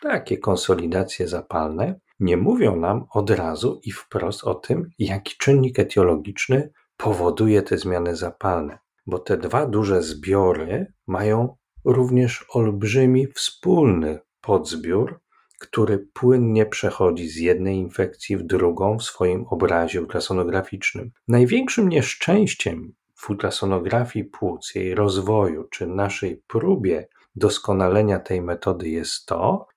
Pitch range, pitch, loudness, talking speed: 90-120 Hz, 100 Hz, -22 LUFS, 115 wpm